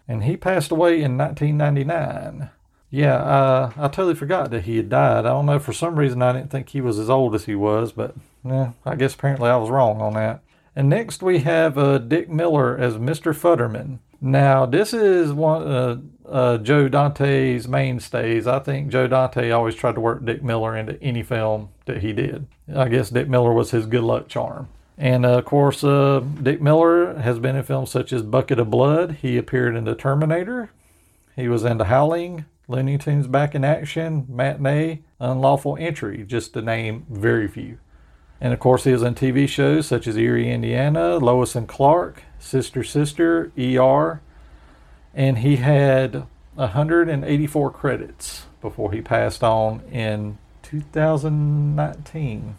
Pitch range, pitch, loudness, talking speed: 120-150 Hz, 130 Hz, -20 LUFS, 175 wpm